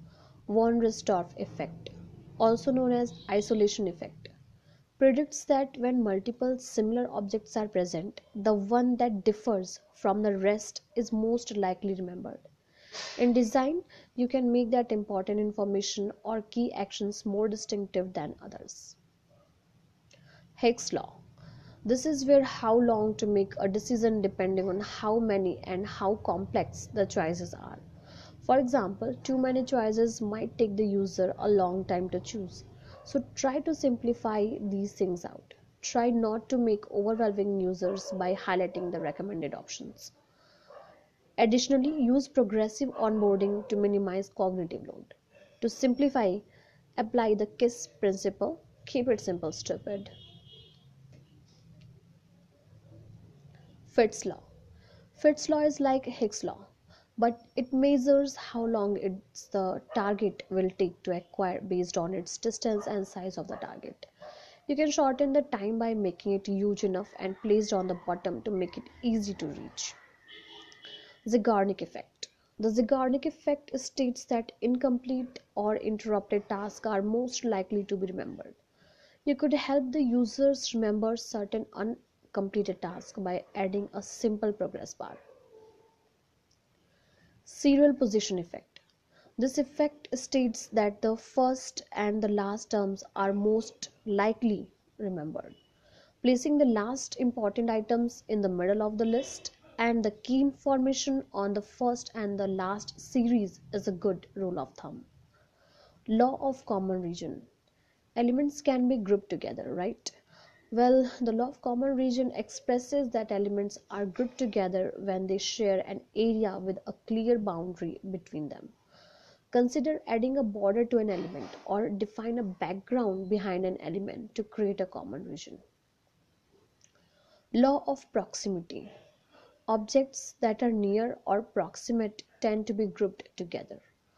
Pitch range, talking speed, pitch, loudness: 195-245 Hz, 135 wpm, 215 Hz, -30 LUFS